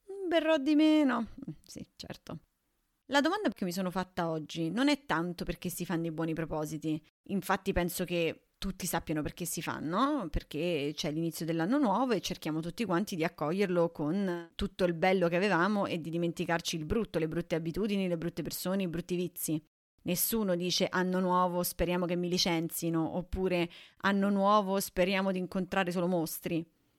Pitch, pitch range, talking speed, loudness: 175 Hz, 165-195 Hz, 170 wpm, -32 LUFS